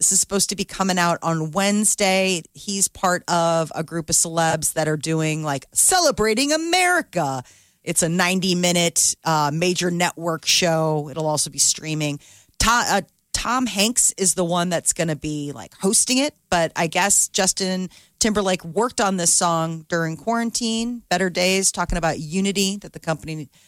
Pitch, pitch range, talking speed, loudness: 175 Hz, 160-195 Hz, 165 wpm, -20 LUFS